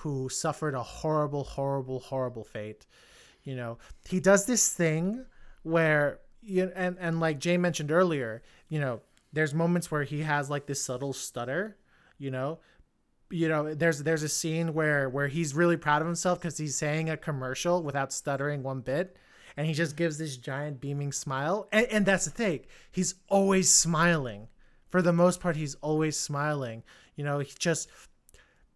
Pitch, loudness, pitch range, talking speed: 155 Hz, -29 LUFS, 140-175 Hz, 175 wpm